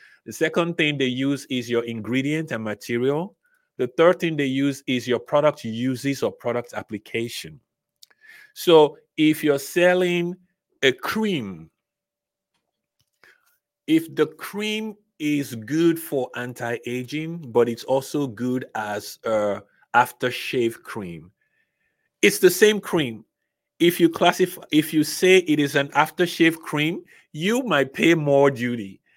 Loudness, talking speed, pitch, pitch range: -22 LUFS, 130 wpm, 150 Hz, 125-175 Hz